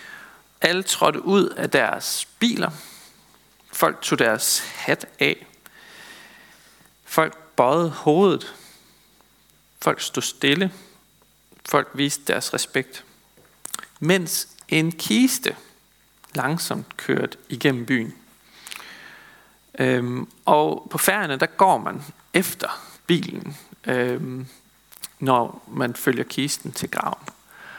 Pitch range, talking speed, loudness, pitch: 130-195 Hz, 95 wpm, -22 LUFS, 165 Hz